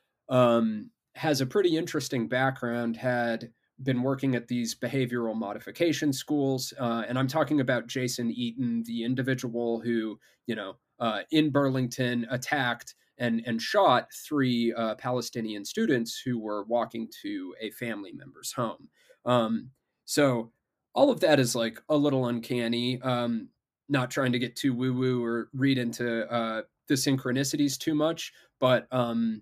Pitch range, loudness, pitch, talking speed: 115-135 Hz, -28 LUFS, 125 Hz, 145 wpm